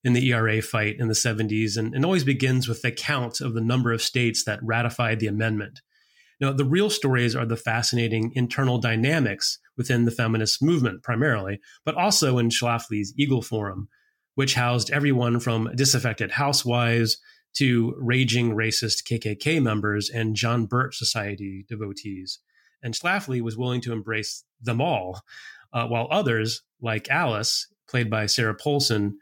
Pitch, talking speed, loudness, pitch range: 120 Hz, 155 wpm, -24 LUFS, 110-130 Hz